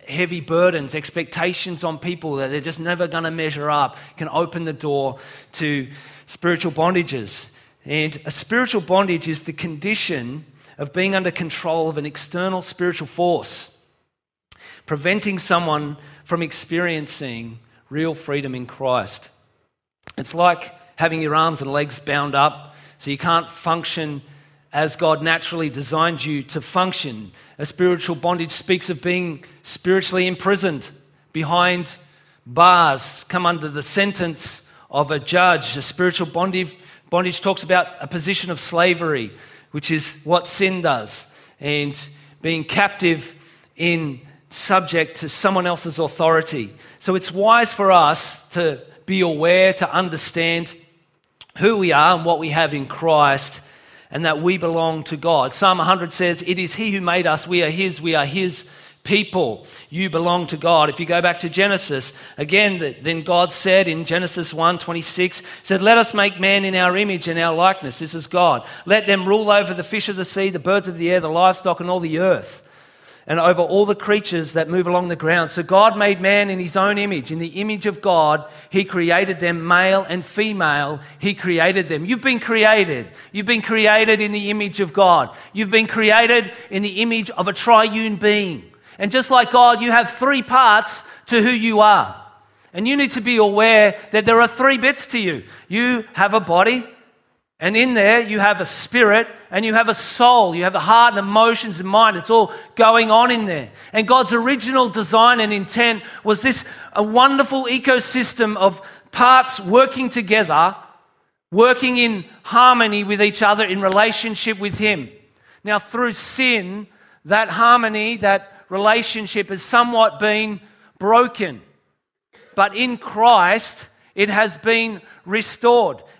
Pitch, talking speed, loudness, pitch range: 180 Hz, 165 wpm, -17 LUFS, 160-210 Hz